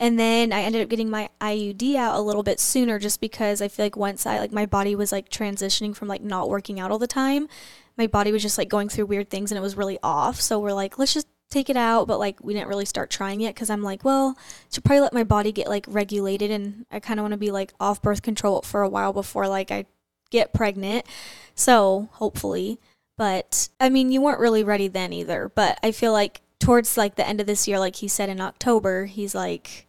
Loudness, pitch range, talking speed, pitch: -23 LUFS, 200-225 Hz, 250 wpm, 210 Hz